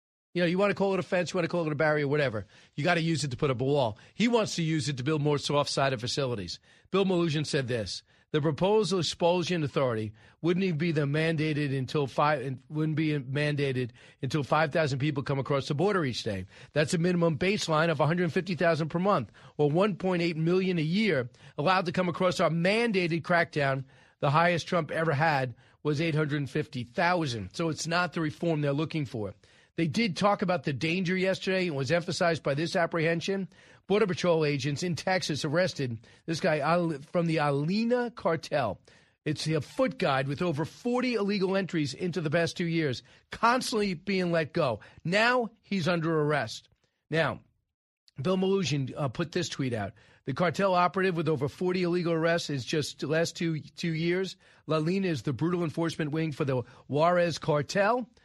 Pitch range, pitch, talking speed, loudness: 145-180 Hz, 165 Hz, 185 wpm, -28 LUFS